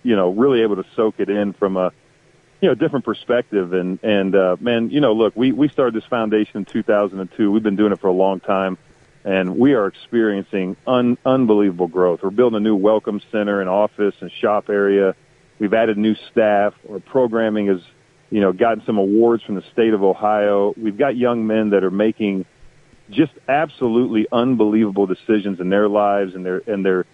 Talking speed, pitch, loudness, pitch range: 195 wpm, 105 Hz, -18 LUFS, 95-110 Hz